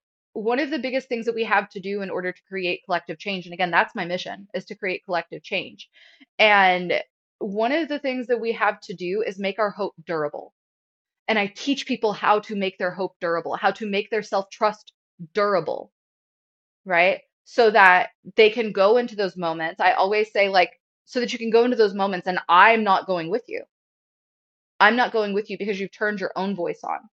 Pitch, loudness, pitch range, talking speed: 205 Hz, -22 LUFS, 185-225 Hz, 215 wpm